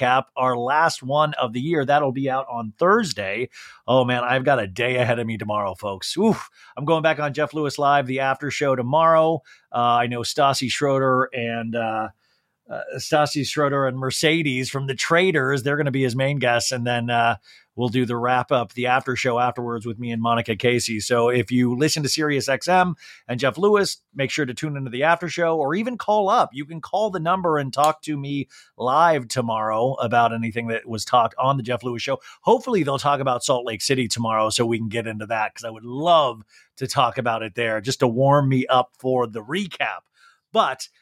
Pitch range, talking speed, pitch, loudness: 120-145 Hz, 215 wpm, 130 Hz, -21 LUFS